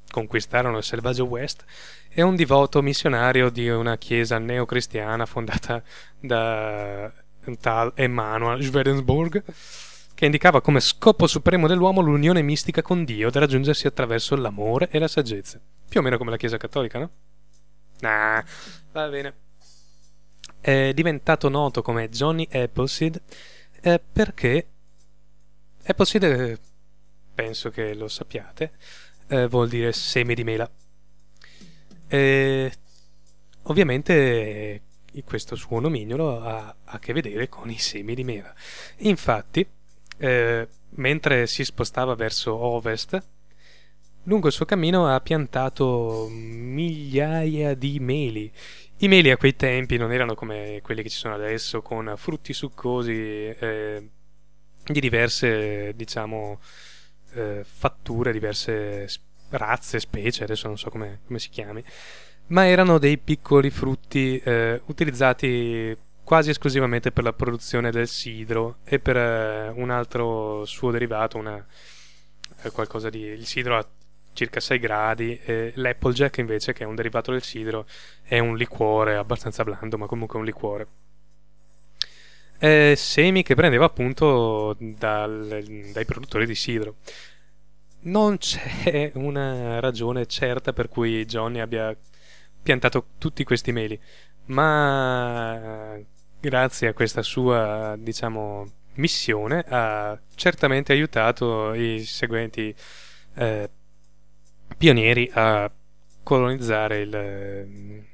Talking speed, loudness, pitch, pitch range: 120 wpm, -23 LUFS, 120 Hz, 110-140 Hz